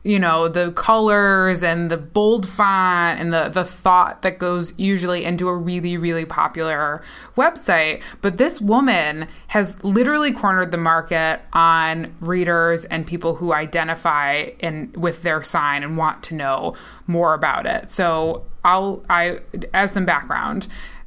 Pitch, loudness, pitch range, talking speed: 175 Hz, -19 LUFS, 160-190 Hz, 150 wpm